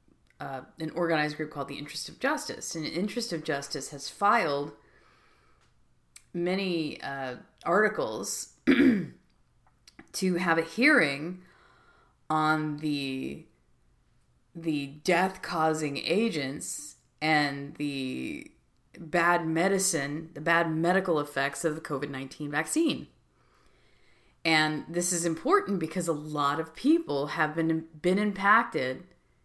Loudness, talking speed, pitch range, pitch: -28 LUFS, 105 wpm, 145-175 Hz, 160 Hz